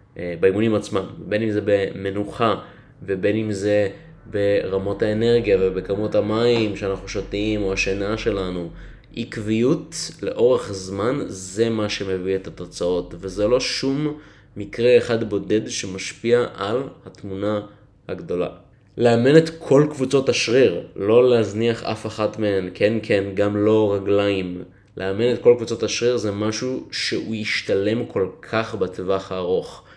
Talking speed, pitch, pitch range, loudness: 130 wpm, 105 Hz, 100-115 Hz, -21 LUFS